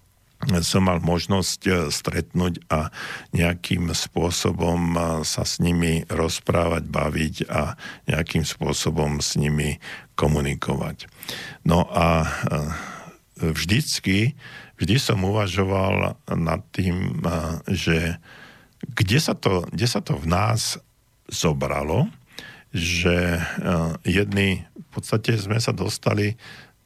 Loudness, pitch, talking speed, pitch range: -23 LUFS, 90 Hz, 95 wpm, 85-105 Hz